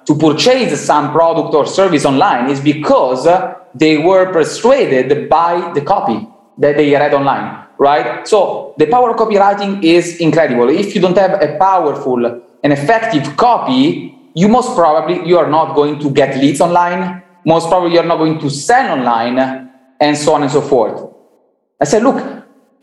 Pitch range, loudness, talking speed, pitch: 145-200 Hz, -12 LUFS, 170 wpm, 170 Hz